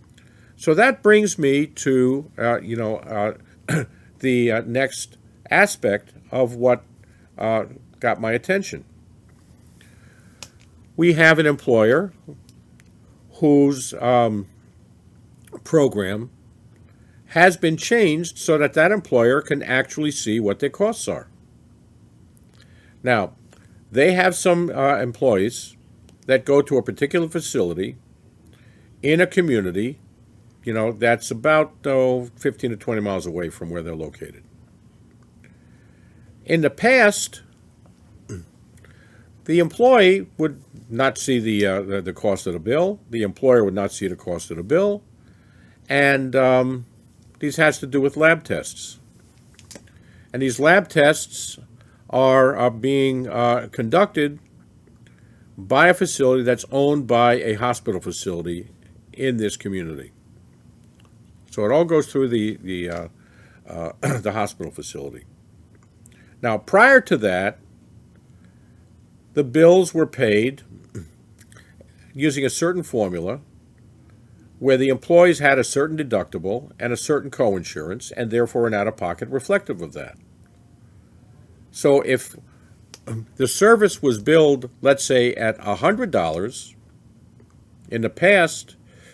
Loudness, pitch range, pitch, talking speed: -19 LUFS, 110-140 Hz, 120 Hz, 120 wpm